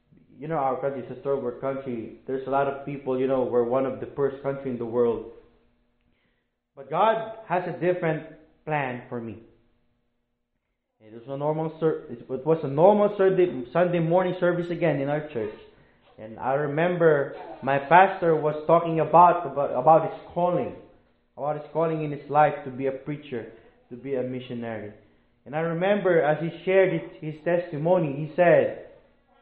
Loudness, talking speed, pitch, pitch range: -24 LUFS, 175 wpm, 145 Hz, 125-170 Hz